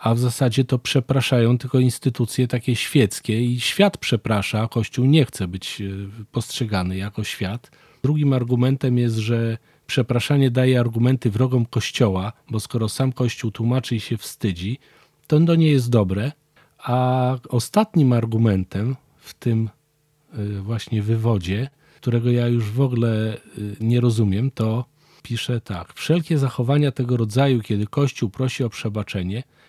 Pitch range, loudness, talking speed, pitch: 110-135 Hz, -21 LUFS, 135 wpm, 120 Hz